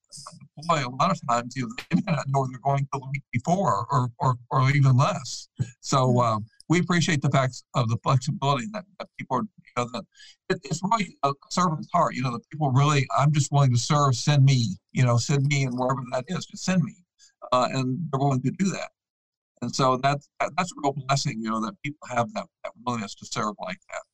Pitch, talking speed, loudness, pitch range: 140 Hz, 225 wpm, -25 LUFS, 130-165 Hz